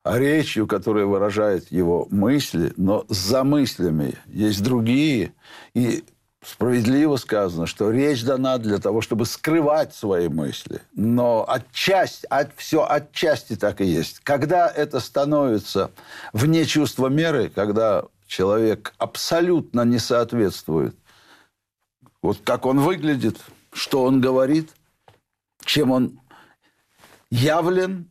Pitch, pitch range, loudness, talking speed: 125 Hz, 105-145 Hz, -21 LUFS, 110 wpm